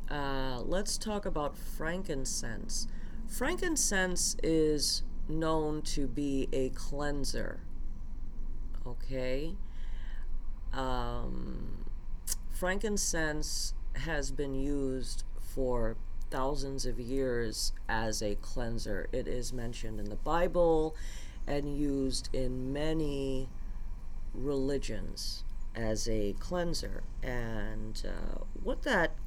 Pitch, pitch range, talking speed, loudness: 130 Hz, 105-150 Hz, 90 wpm, -35 LUFS